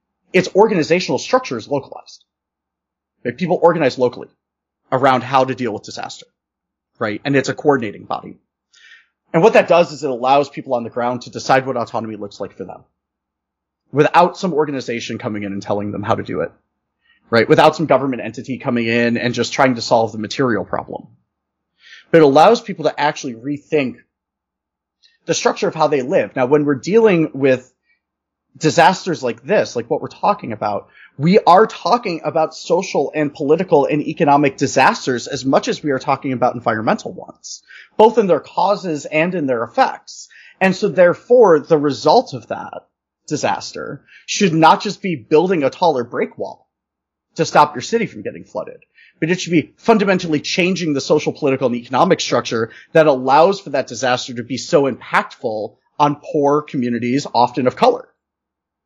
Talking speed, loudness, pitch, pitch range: 175 wpm, -16 LUFS, 145 Hz, 125-170 Hz